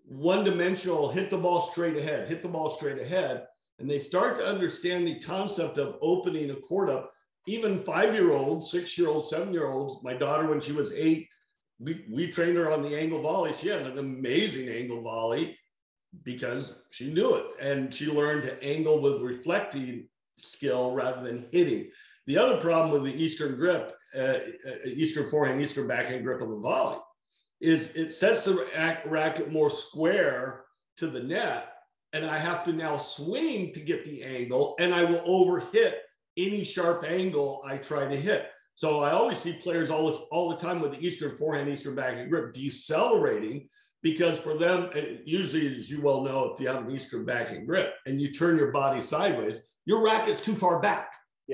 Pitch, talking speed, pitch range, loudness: 160 Hz, 190 wpm, 140-180 Hz, -28 LUFS